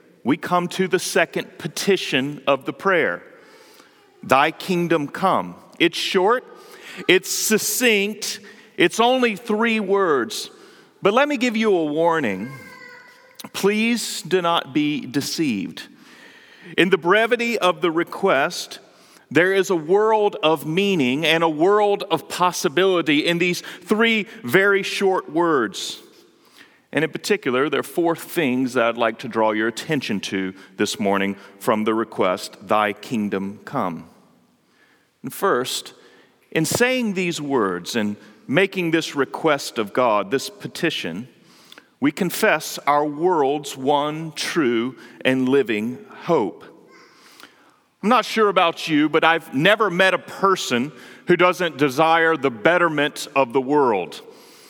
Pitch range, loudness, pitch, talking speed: 145-215 Hz, -20 LUFS, 175 Hz, 130 wpm